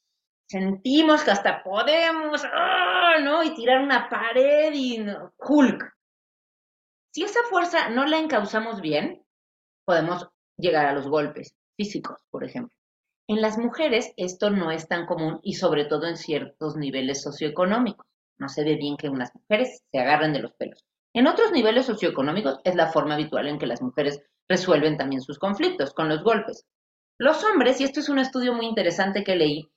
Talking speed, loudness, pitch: 170 wpm, -23 LUFS, 190 Hz